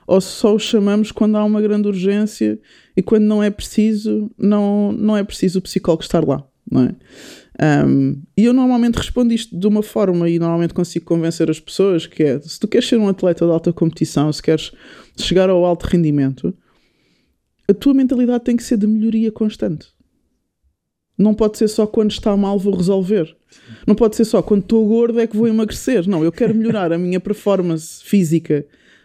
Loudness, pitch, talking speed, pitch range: -16 LUFS, 200 Hz, 190 wpm, 170-220 Hz